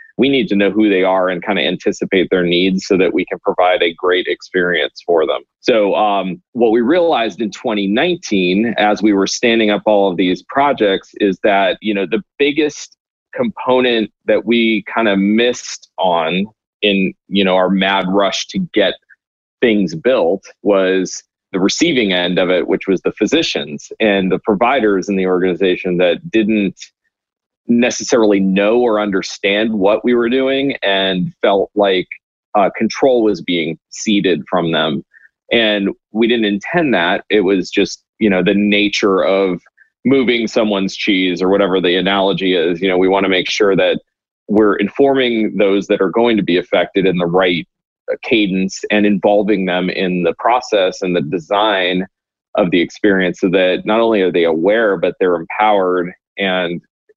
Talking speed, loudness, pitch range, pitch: 170 wpm, -15 LUFS, 95-110 Hz, 100 Hz